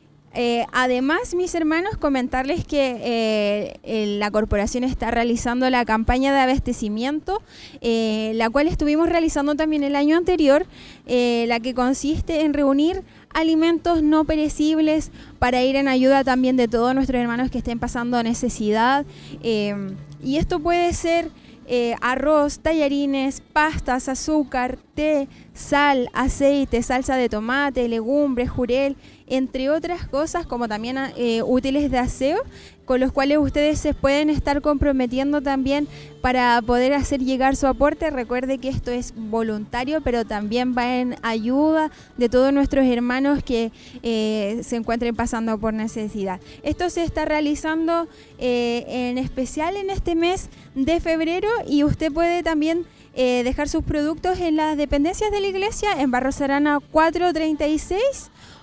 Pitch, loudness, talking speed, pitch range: 270 Hz, -21 LUFS, 145 wpm, 245-305 Hz